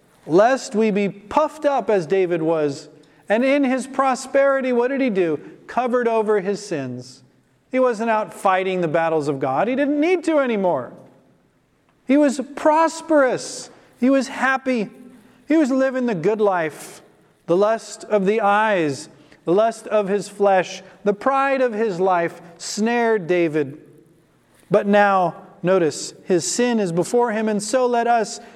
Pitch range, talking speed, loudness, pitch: 180-255 Hz, 155 wpm, -20 LUFS, 215 Hz